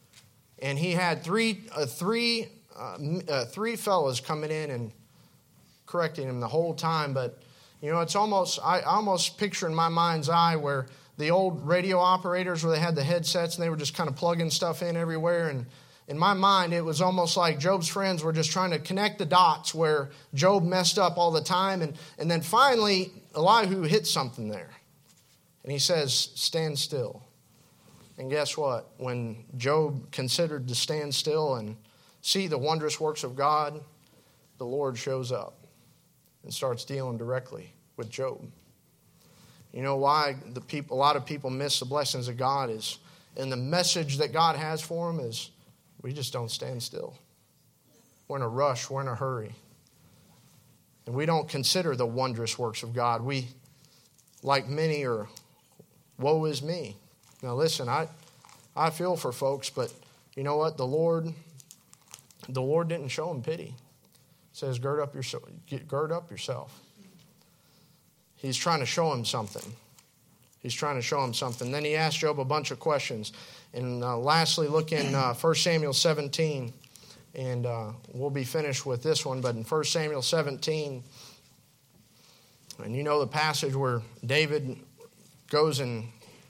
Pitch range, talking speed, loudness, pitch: 130-165 Hz, 170 wpm, -28 LUFS, 150 Hz